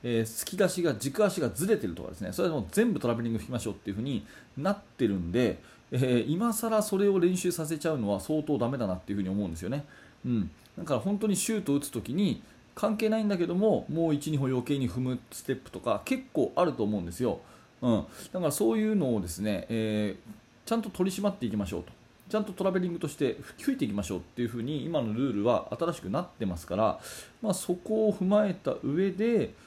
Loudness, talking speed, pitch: -30 LUFS, 460 characters per minute, 150 Hz